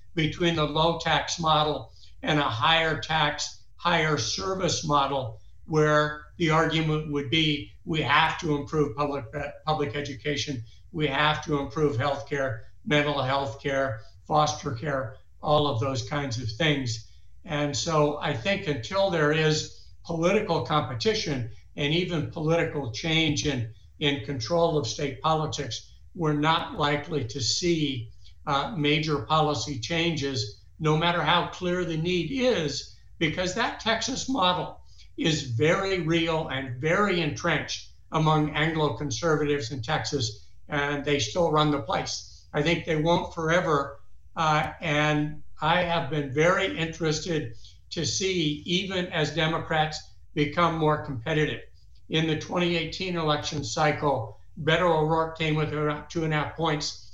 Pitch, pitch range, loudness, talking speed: 150 Hz, 140-160 Hz, -26 LUFS, 140 wpm